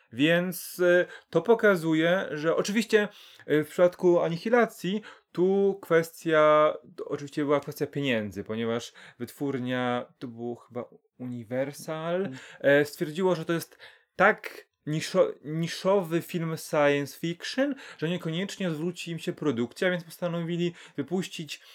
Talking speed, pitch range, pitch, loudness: 110 wpm, 145-180 Hz, 165 Hz, -27 LUFS